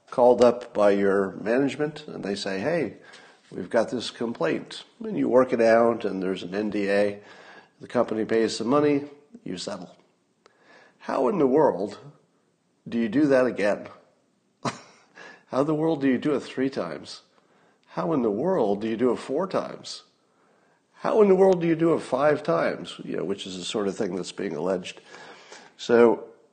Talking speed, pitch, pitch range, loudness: 180 wpm, 120 Hz, 105-145 Hz, -24 LUFS